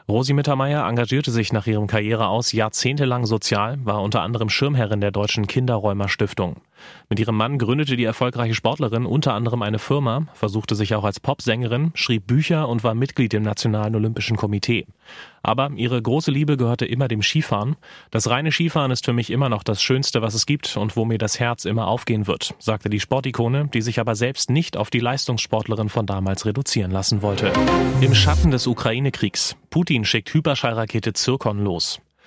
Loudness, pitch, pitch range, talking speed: -21 LUFS, 115 Hz, 110-130 Hz, 180 wpm